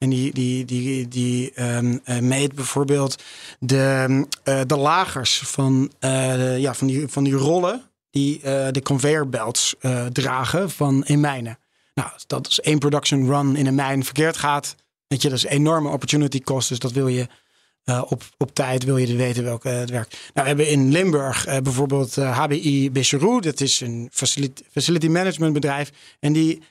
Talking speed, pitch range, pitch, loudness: 190 wpm, 130-145 Hz, 135 Hz, -21 LUFS